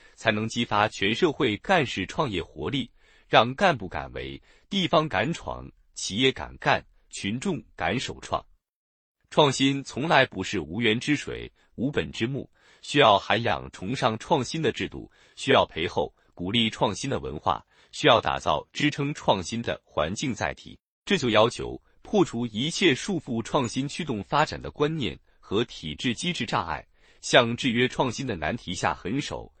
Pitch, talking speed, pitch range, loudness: 120 Hz, 235 characters per minute, 105-140 Hz, -26 LUFS